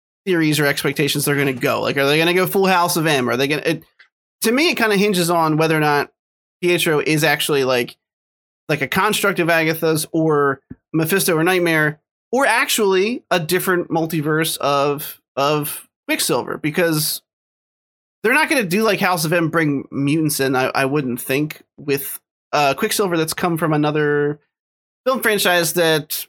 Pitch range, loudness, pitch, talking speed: 145-180 Hz, -18 LUFS, 160 Hz, 180 wpm